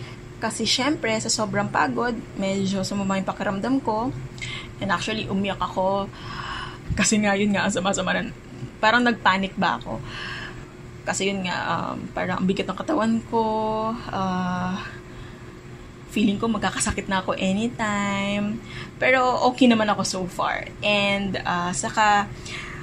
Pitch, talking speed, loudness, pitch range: 200 Hz, 130 wpm, -24 LUFS, 185-220 Hz